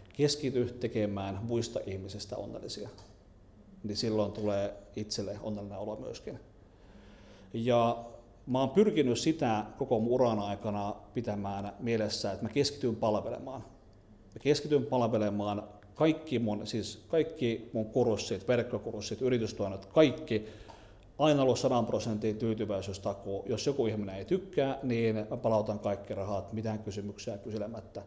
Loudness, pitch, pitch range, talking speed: -32 LUFS, 110 Hz, 105-120 Hz, 120 wpm